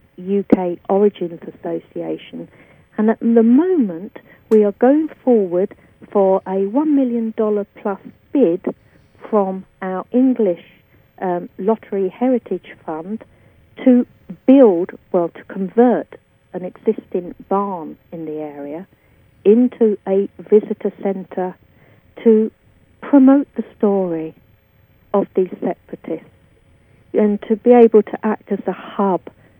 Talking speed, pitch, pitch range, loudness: 110 wpm, 200 Hz, 180-230 Hz, -17 LUFS